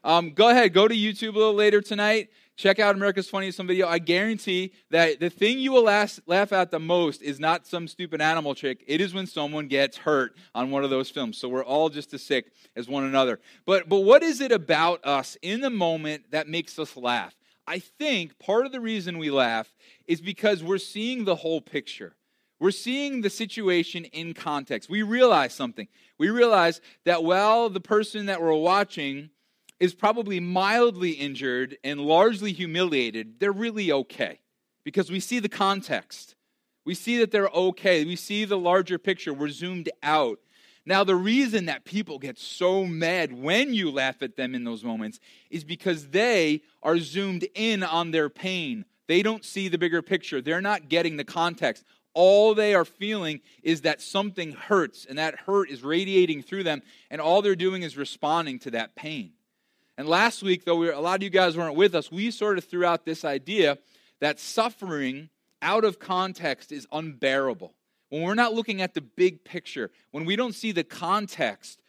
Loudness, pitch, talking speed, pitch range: -25 LUFS, 180 Hz, 190 wpm, 155-205 Hz